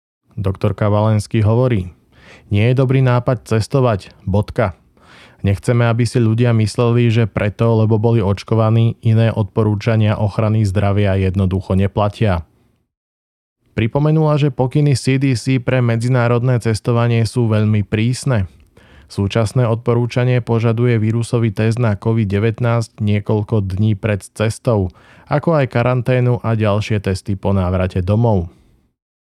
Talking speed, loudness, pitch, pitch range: 115 wpm, -16 LUFS, 110 Hz, 105-120 Hz